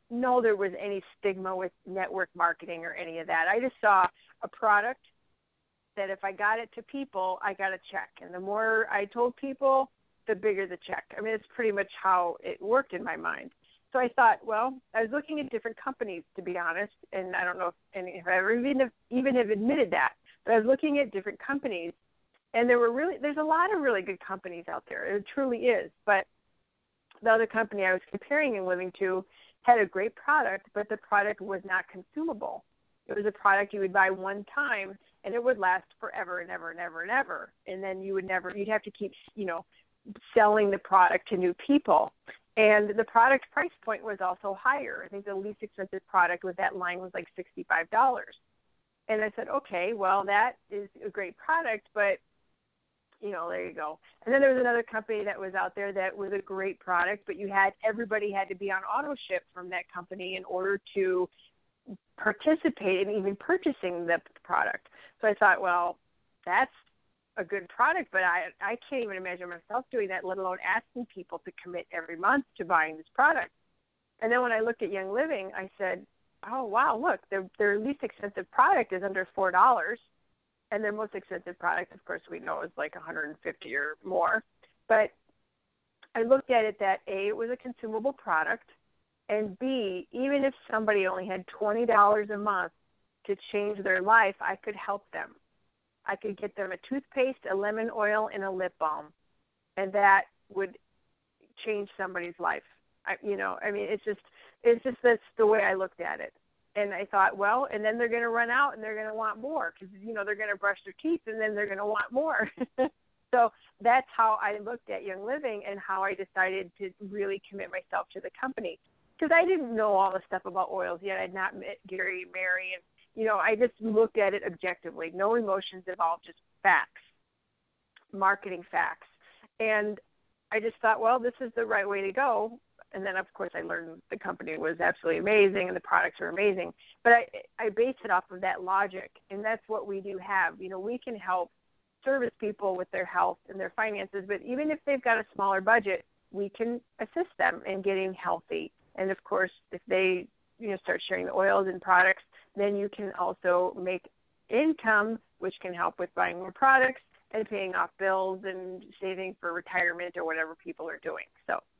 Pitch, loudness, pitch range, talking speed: 205 Hz, -29 LUFS, 185-230 Hz, 205 wpm